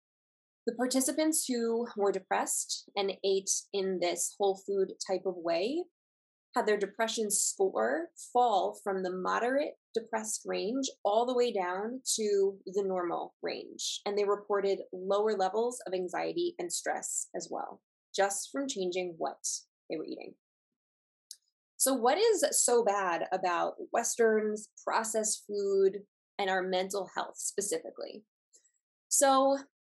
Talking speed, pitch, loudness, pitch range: 130 wpm, 210 Hz, -31 LUFS, 195-265 Hz